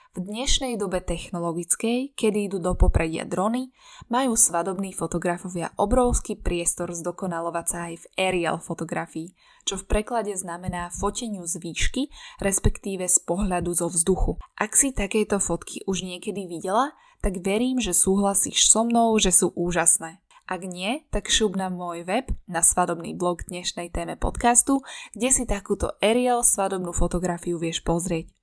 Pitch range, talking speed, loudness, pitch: 175-215 Hz, 145 wpm, -23 LUFS, 190 Hz